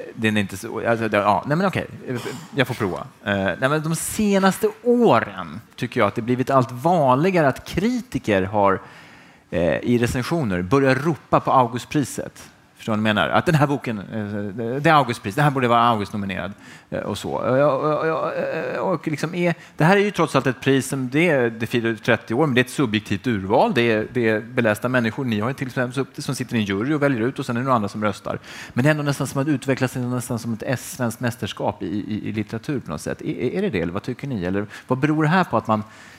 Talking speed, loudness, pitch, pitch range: 230 wpm, -21 LUFS, 125 Hz, 110-150 Hz